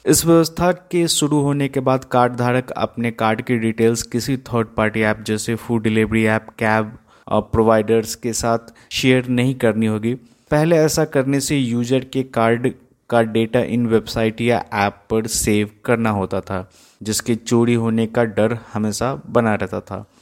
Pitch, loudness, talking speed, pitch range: 115 Hz, -19 LUFS, 170 wpm, 110-125 Hz